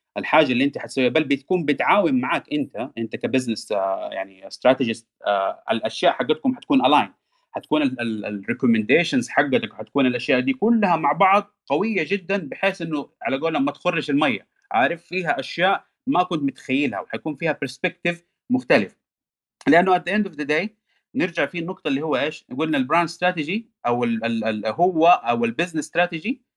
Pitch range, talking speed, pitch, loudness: 140-215 Hz, 150 wpm, 175 Hz, -22 LUFS